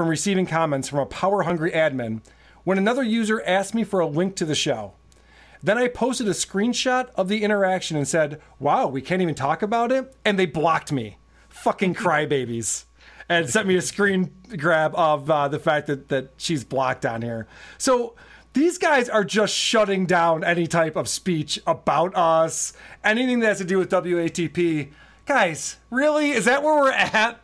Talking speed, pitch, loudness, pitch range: 185 wpm, 175 Hz, -22 LUFS, 150-215 Hz